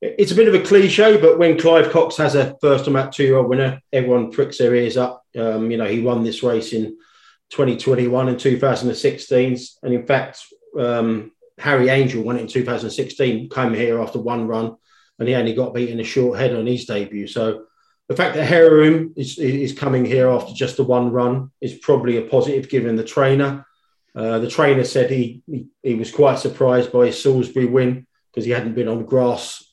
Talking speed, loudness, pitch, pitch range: 200 wpm, -18 LUFS, 125 Hz, 120-140 Hz